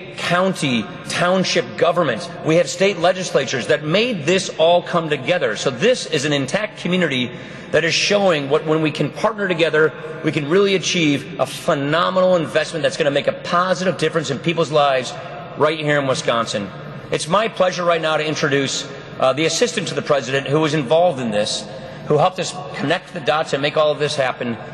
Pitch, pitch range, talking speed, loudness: 165 Hz, 150-180 Hz, 190 wpm, -18 LUFS